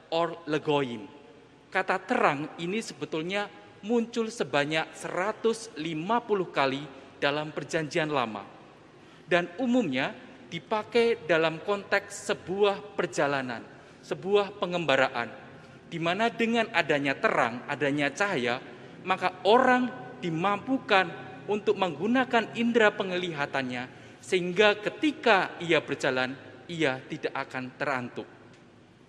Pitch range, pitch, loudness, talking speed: 145-210 Hz, 175 Hz, -28 LUFS, 90 wpm